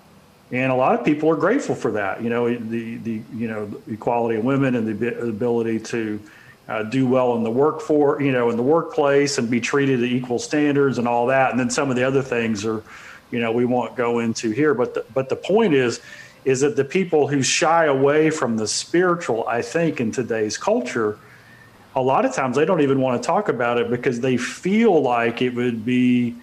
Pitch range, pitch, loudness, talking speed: 115-140 Hz, 125 Hz, -20 LUFS, 225 wpm